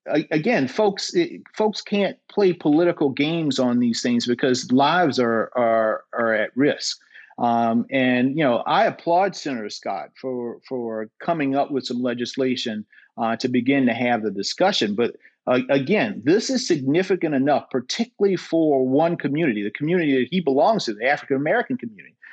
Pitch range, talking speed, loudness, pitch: 120-175 Hz, 160 wpm, -21 LUFS, 135 Hz